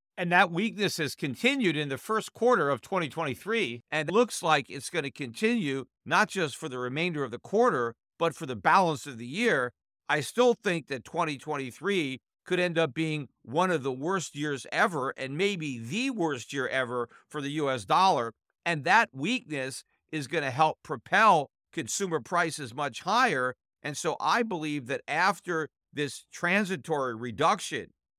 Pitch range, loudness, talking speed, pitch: 135-180 Hz, -28 LUFS, 170 wpm, 155 Hz